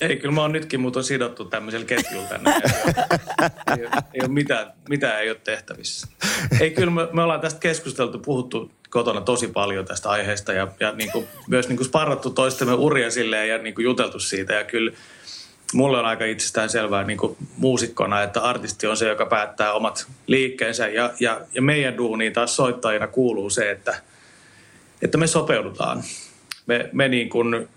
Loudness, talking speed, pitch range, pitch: -22 LUFS, 175 wpm, 110-130 Hz, 120 Hz